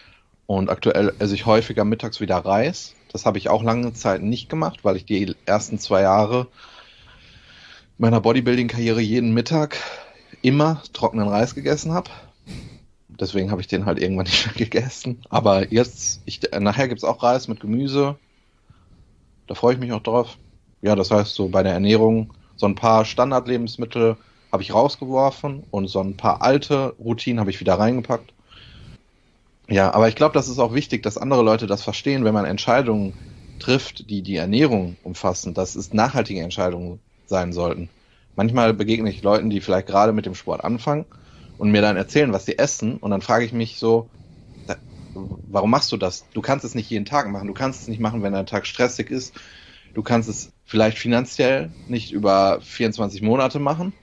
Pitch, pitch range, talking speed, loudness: 110 Hz, 100-120 Hz, 180 wpm, -21 LUFS